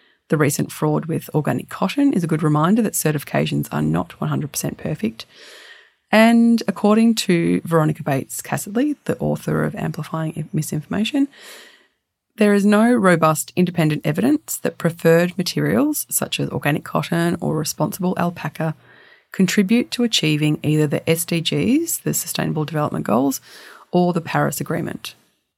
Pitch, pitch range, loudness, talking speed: 170 Hz, 155-215 Hz, -19 LUFS, 135 wpm